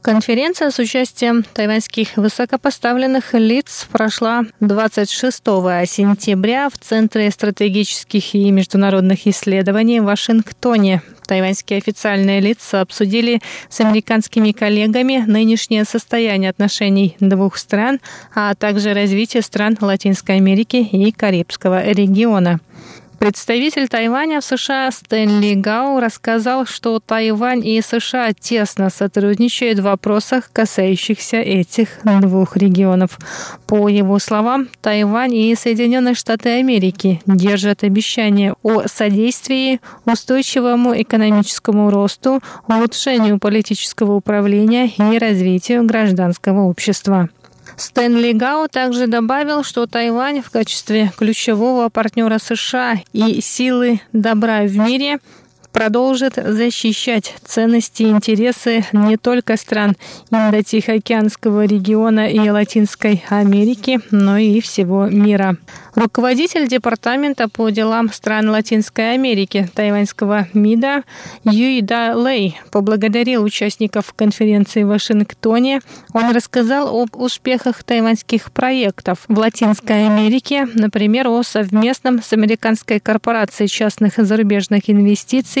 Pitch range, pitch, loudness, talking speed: 205-235 Hz, 220 Hz, -15 LUFS, 105 wpm